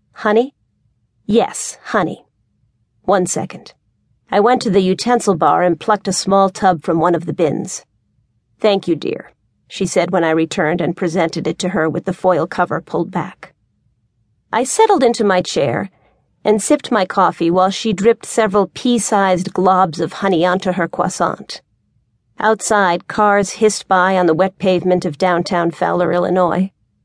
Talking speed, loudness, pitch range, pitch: 160 wpm, -16 LUFS, 165-195 Hz, 180 Hz